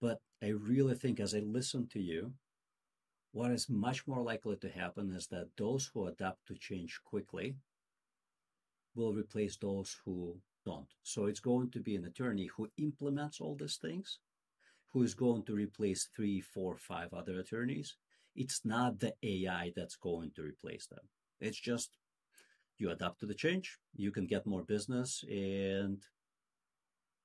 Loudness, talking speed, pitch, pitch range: -39 LUFS, 160 wpm, 105 Hz, 95-125 Hz